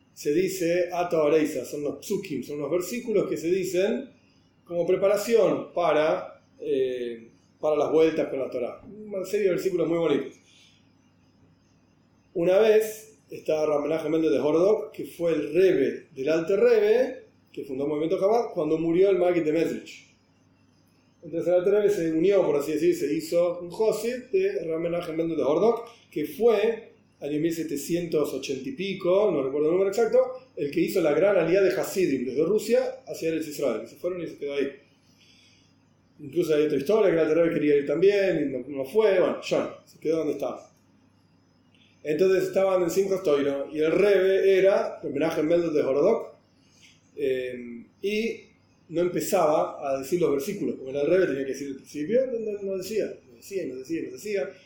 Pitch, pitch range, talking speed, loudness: 175 Hz, 150-205 Hz, 175 wpm, -25 LUFS